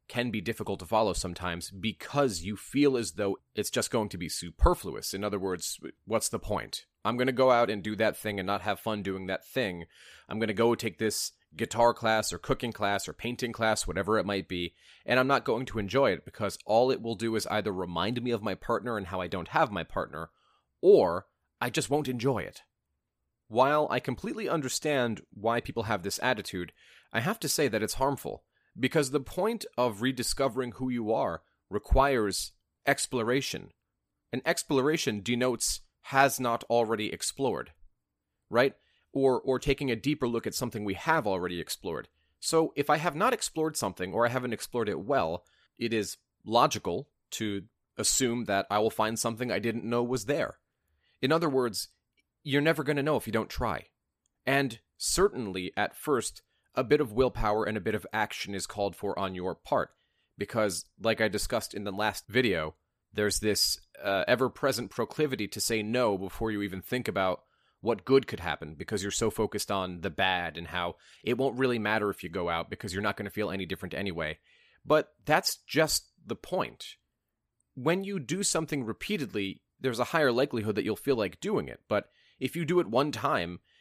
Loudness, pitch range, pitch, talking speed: -30 LUFS, 100-130 Hz, 110 Hz, 195 wpm